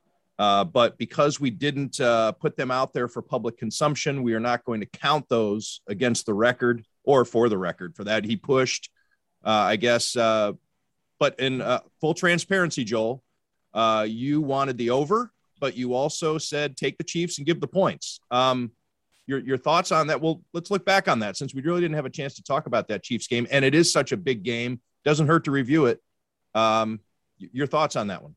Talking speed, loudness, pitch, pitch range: 210 wpm, -24 LUFS, 130 Hz, 115-150 Hz